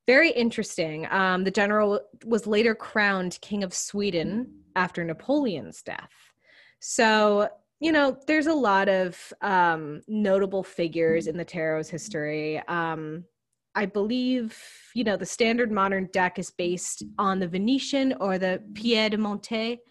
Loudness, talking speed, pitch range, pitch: -25 LUFS, 140 wpm, 175-225 Hz, 195 Hz